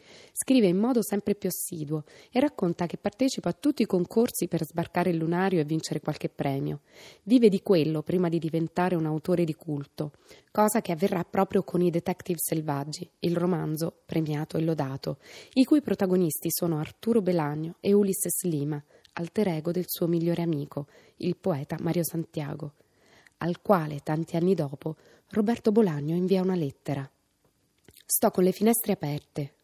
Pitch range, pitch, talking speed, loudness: 155-195 Hz, 175 Hz, 160 wpm, -27 LUFS